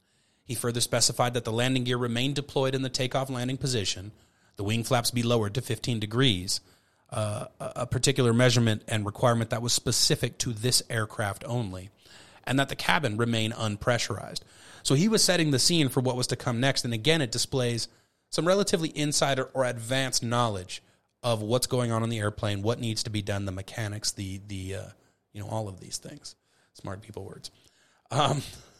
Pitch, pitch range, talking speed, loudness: 120 Hz, 110-130 Hz, 190 wpm, -27 LUFS